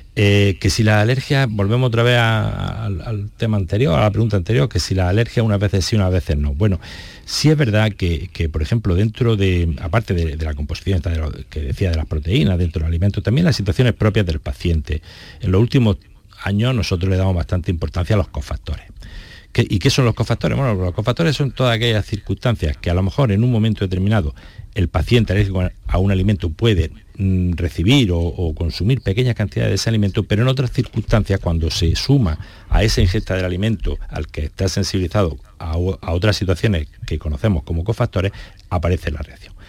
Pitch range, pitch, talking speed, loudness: 85-110 Hz, 100 Hz, 205 wpm, -18 LUFS